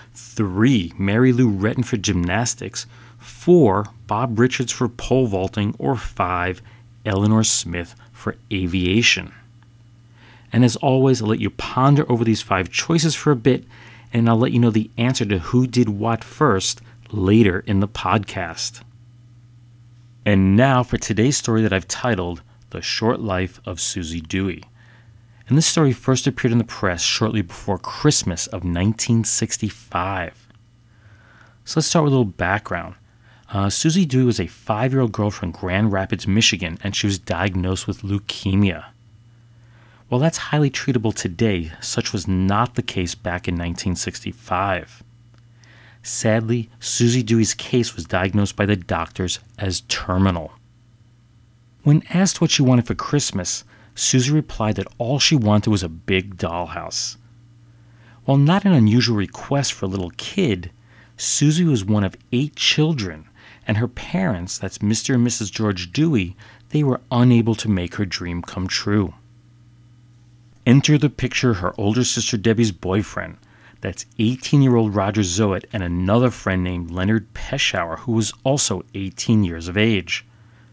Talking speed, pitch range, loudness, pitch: 150 wpm, 100-120 Hz, -20 LUFS, 115 Hz